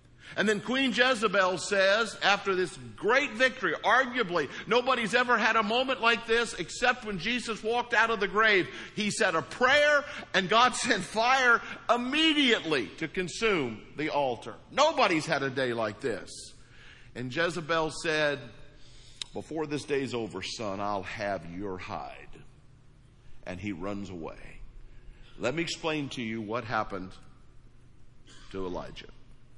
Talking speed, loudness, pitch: 140 wpm, -27 LUFS, 170 Hz